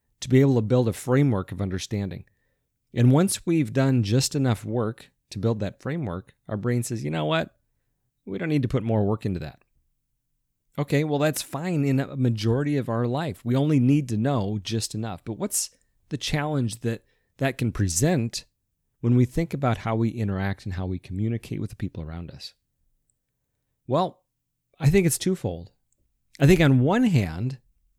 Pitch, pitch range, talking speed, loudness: 125 Hz, 110-135 Hz, 185 wpm, -25 LUFS